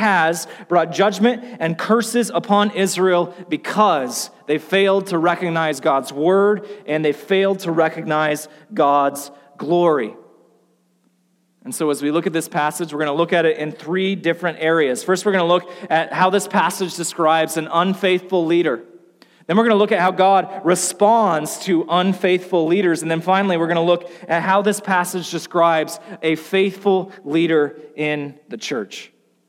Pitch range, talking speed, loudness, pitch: 160-190 Hz, 165 wpm, -18 LUFS, 175 Hz